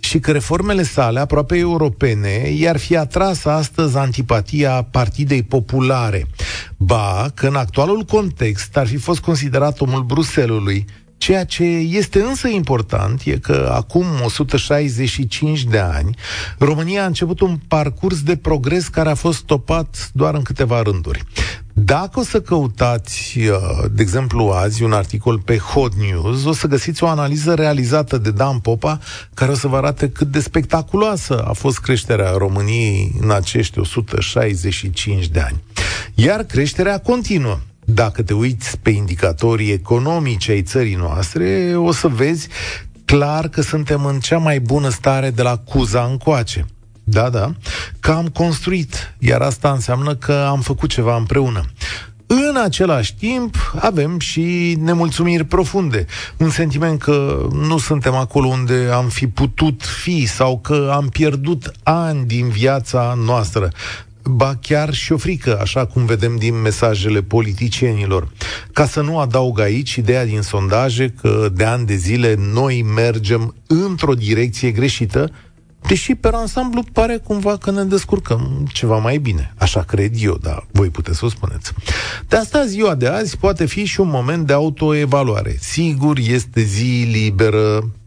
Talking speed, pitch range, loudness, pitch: 150 wpm, 110-155 Hz, -17 LUFS, 130 Hz